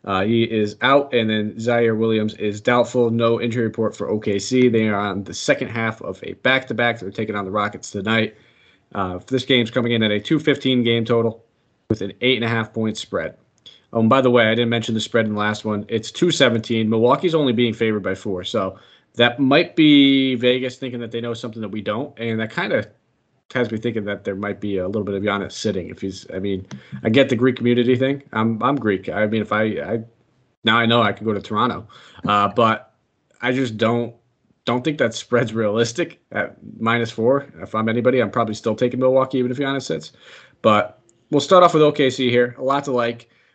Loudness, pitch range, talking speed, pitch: -20 LUFS, 105-125 Hz, 220 wpm, 115 Hz